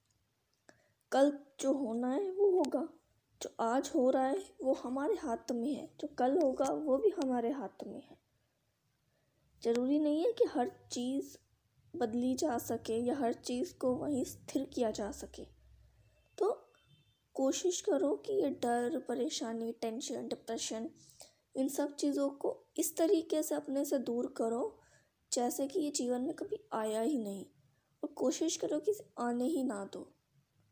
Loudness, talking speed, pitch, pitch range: -35 LUFS, 160 wpm, 275 Hz, 245-315 Hz